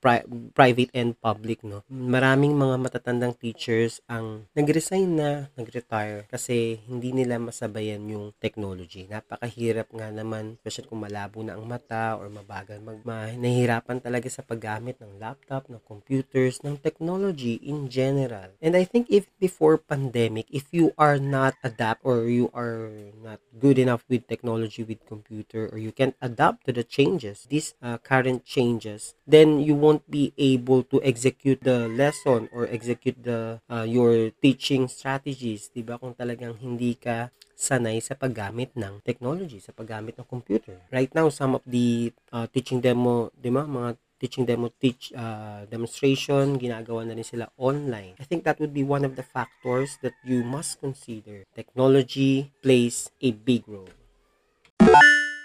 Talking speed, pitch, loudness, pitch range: 155 wpm, 120 Hz, -24 LUFS, 115-135 Hz